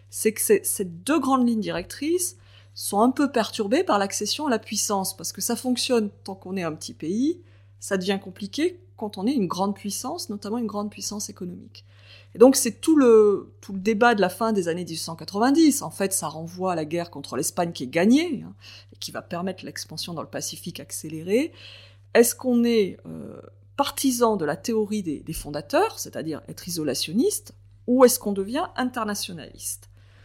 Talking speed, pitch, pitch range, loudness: 190 wpm, 200 Hz, 155-235 Hz, -24 LUFS